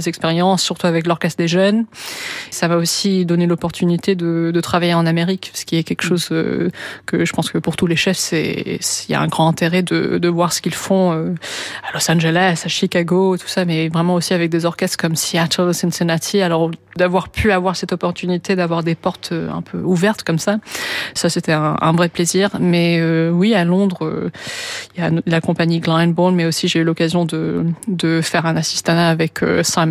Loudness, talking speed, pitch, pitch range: -17 LUFS, 210 wpm, 170 Hz, 165-185 Hz